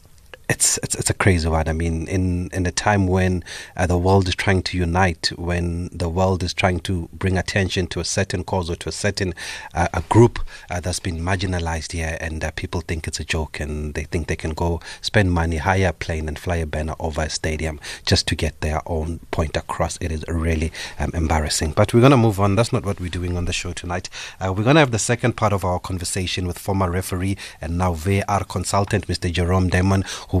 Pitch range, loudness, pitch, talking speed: 80-95 Hz, -21 LUFS, 90 Hz, 235 wpm